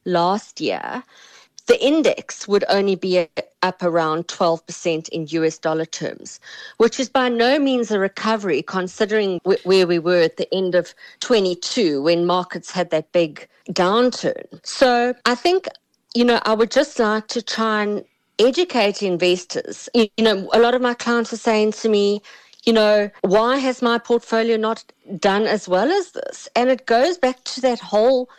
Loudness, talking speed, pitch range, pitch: -19 LUFS, 175 wpm, 185-245 Hz, 220 Hz